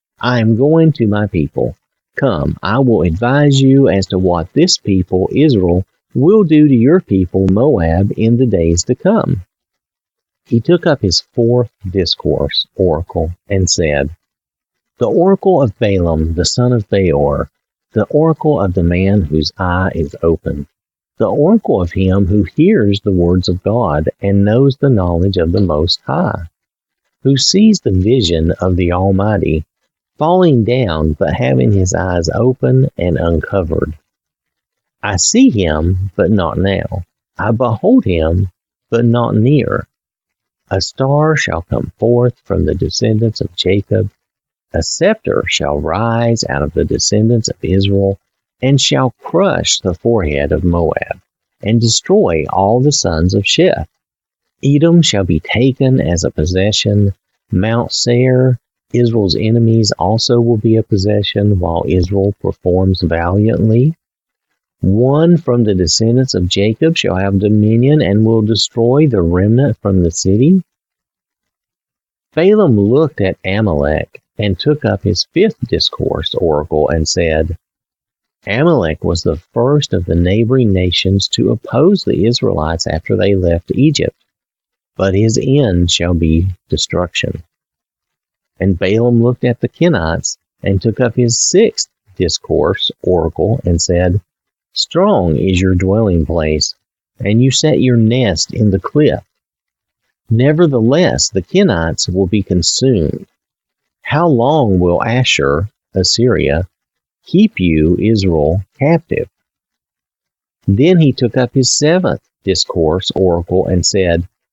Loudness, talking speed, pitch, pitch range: -13 LUFS, 135 wpm, 100 Hz, 90-125 Hz